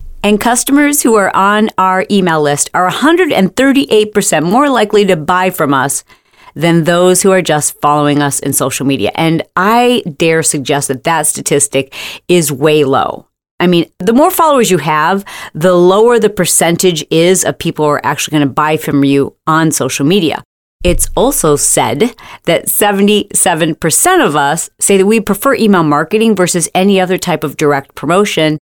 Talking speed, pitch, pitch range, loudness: 170 wpm, 175 Hz, 150-205 Hz, -10 LUFS